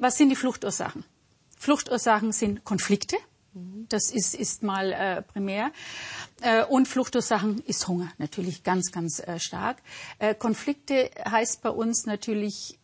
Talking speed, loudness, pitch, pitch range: 135 wpm, -27 LUFS, 220 Hz, 195-245 Hz